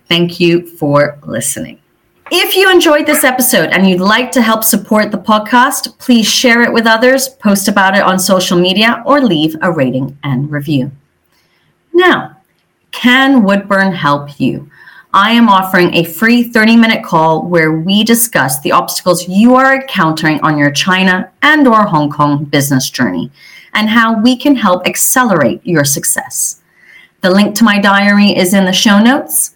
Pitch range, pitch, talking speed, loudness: 170-235 Hz, 200 Hz, 165 wpm, -9 LUFS